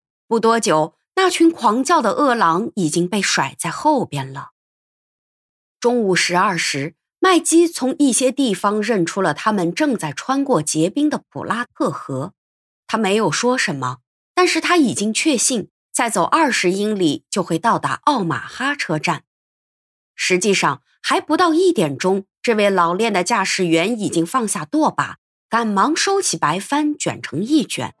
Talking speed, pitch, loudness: 230 characters per minute, 215 Hz, -18 LUFS